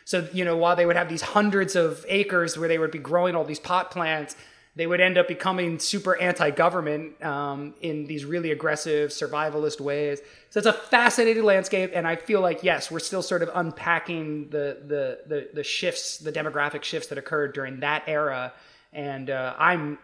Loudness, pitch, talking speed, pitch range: -25 LUFS, 165 Hz, 195 wpm, 150-180 Hz